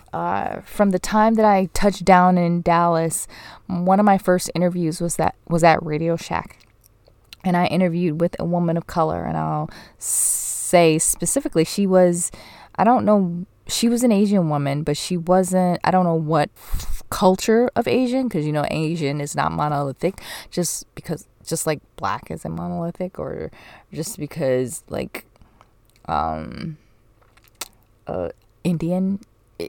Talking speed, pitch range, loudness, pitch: 150 wpm, 150-185 Hz, -20 LUFS, 170 Hz